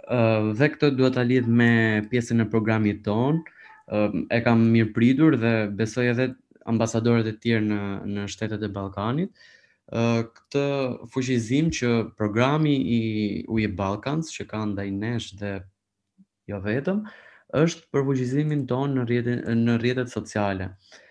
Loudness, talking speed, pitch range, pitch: -24 LUFS, 140 wpm, 105-130 Hz, 115 Hz